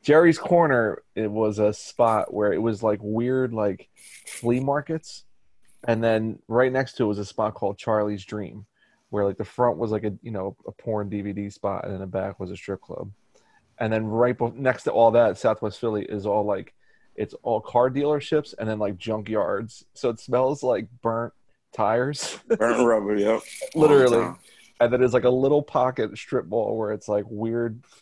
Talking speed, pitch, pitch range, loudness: 195 wpm, 115 Hz, 105-125 Hz, -24 LUFS